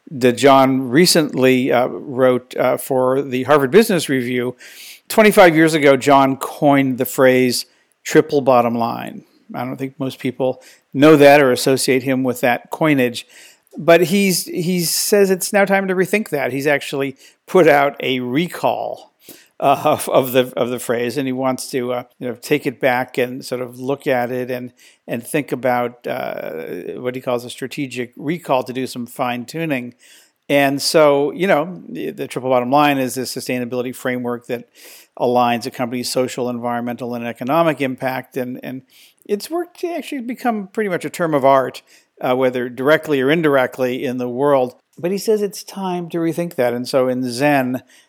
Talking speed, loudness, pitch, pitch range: 180 wpm, -17 LUFS, 130 Hz, 125-155 Hz